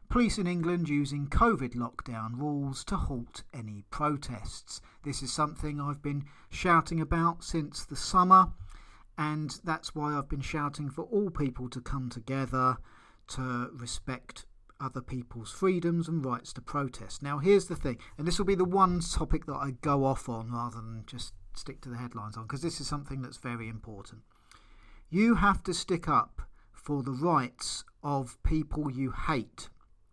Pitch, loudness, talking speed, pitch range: 140 Hz, -31 LUFS, 170 wpm, 120-160 Hz